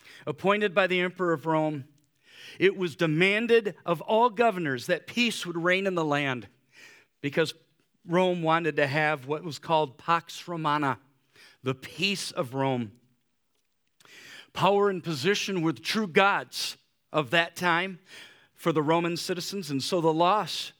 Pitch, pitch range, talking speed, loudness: 165 Hz, 145-185 Hz, 145 wpm, -27 LUFS